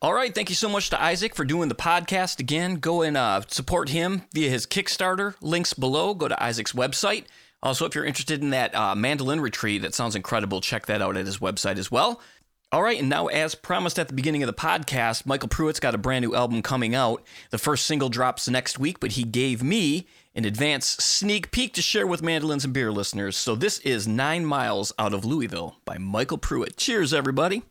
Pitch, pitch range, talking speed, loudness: 140 Hz, 115-170 Hz, 220 wpm, -25 LUFS